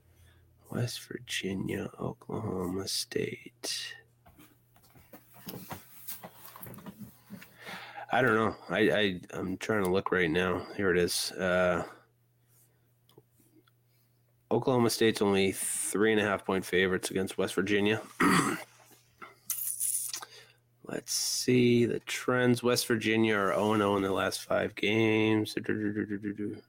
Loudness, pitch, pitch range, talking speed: -29 LUFS, 110 Hz, 100-120 Hz, 105 wpm